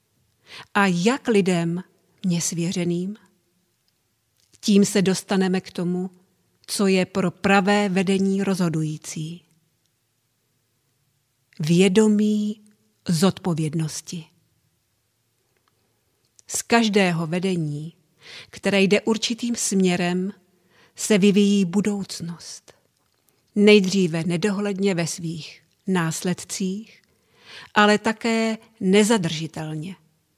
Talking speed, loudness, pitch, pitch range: 70 wpm, -21 LUFS, 180 Hz, 160-200 Hz